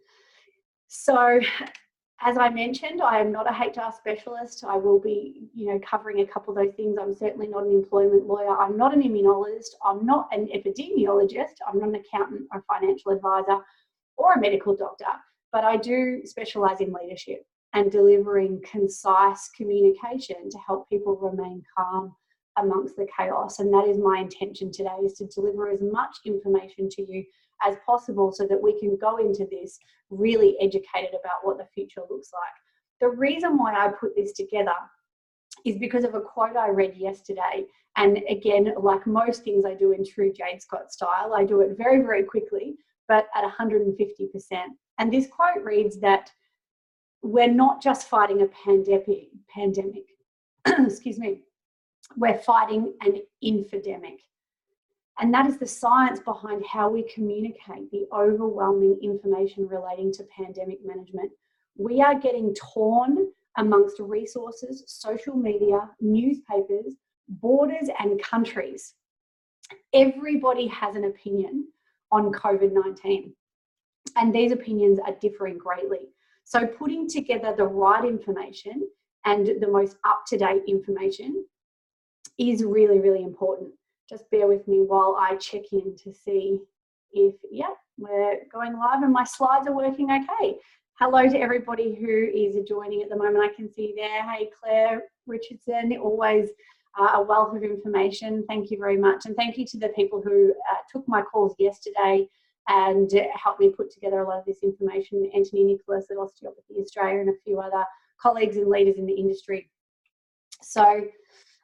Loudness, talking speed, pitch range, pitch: -24 LUFS, 155 wpm, 195-245 Hz, 210 Hz